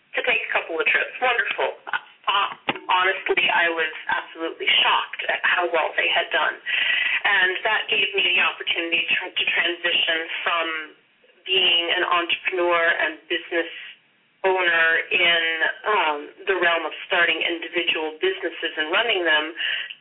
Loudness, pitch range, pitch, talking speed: -20 LUFS, 165-180 Hz, 170 Hz, 140 wpm